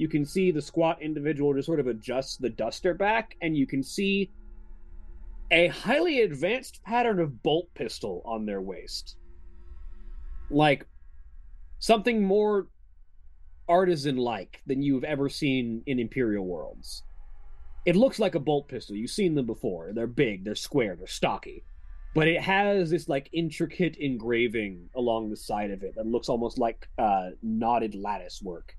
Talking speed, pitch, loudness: 155 wpm, 130 Hz, -27 LUFS